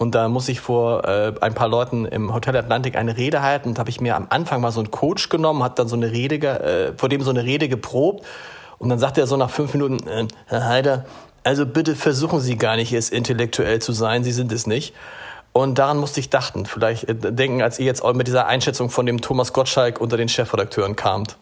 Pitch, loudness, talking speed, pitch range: 125 Hz, -20 LUFS, 240 wpm, 115-135 Hz